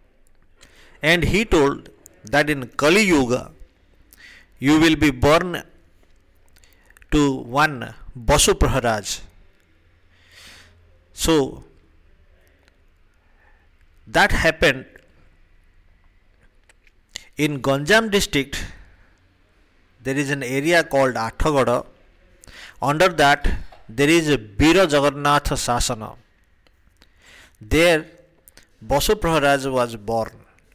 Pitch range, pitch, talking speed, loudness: 85-145 Hz, 105 Hz, 80 wpm, -19 LUFS